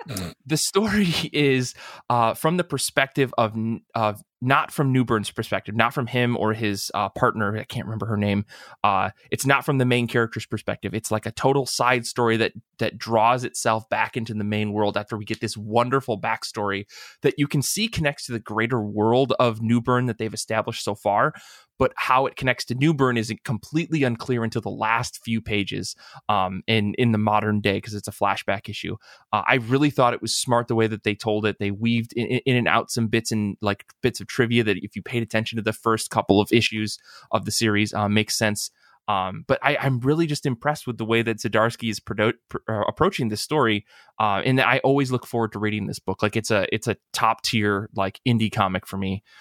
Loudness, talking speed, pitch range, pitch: -23 LUFS, 215 wpm, 105-125 Hz, 115 Hz